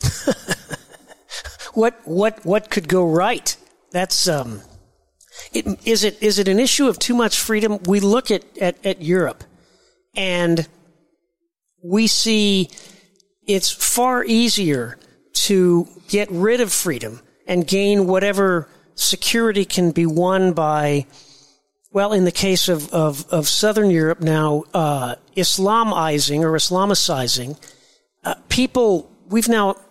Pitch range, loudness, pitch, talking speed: 160-205 Hz, -18 LUFS, 185 Hz, 125 wpm